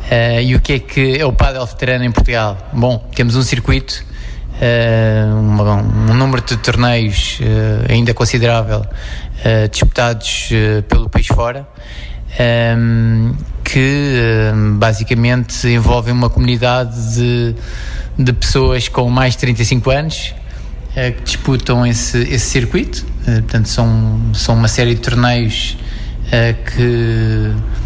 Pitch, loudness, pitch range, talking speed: 115 Hz, -14 LUFS, 110-125 Hz, 135 wpm